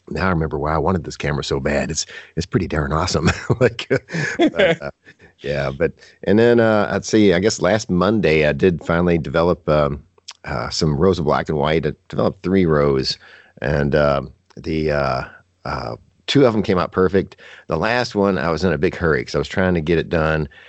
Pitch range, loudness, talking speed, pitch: 75-95 Hz, -19 LUFS, 210 wpm, 85 Hz